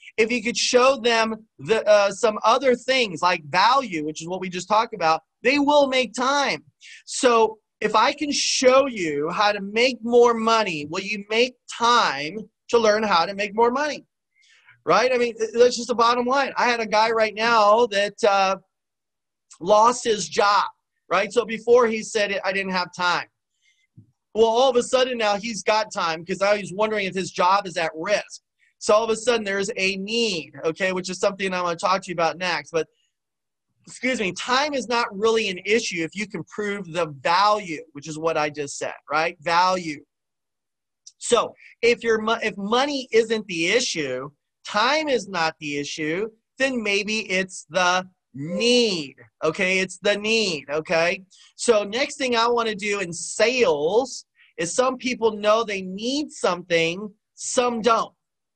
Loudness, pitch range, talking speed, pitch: -21 LUFS, 180-240 Hz, 180 wpm, 215 Hz